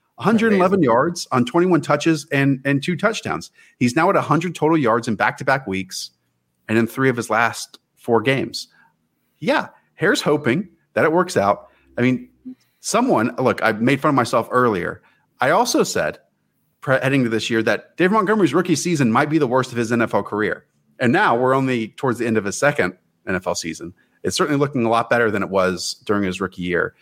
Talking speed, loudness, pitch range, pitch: 200 wpm, -19 LUFS, 115-160 Hz, 130 Hz